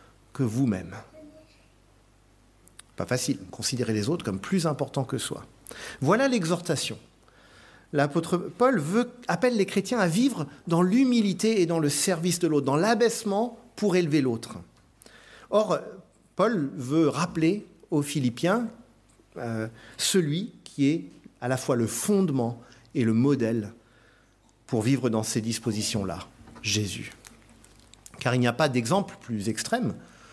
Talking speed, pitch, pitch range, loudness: 135 wpm, 140 Hz, 115-180 Hz, -26 LUFS